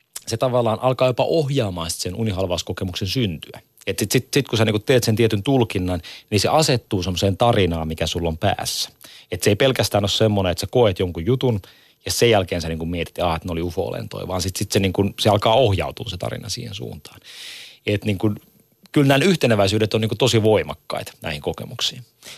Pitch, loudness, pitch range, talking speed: 110 Hz, -20 LUFS, 95-125 Hz, 200 wpm